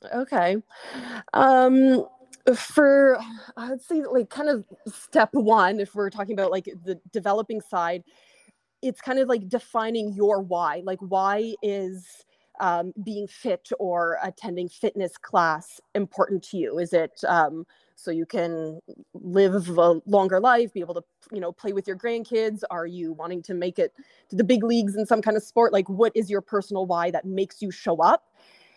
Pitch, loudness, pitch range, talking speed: 200 Hz, -24 LUFS, 180-230 Hz, 175 wpm